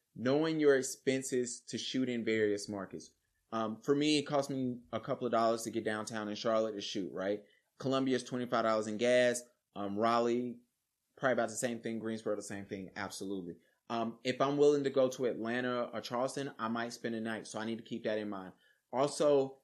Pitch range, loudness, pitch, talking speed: 110-130 Hz, -34 LUFS, 115 Hz, 205 wpm